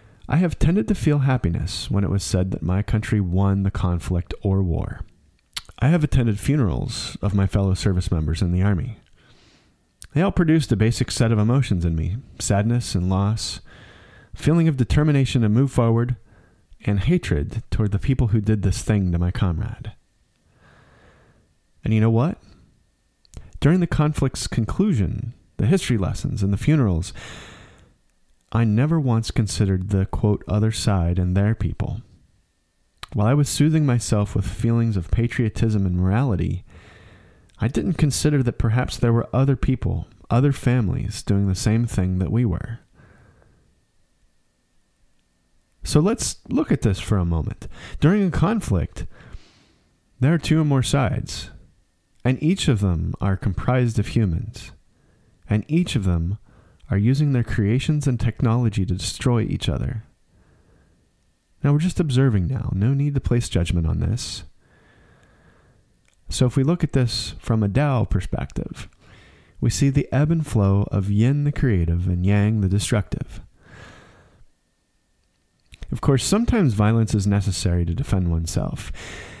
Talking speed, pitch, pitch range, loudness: 150 wpm, 110 Hz, 95-130 Hz, -21 LUFS